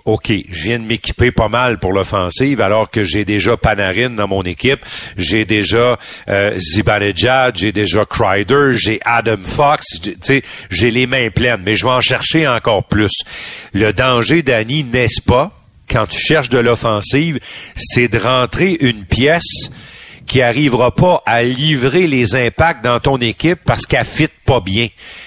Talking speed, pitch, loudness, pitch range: 165 wpm, 120 Hz, -13 LUFS, 105-130 Hz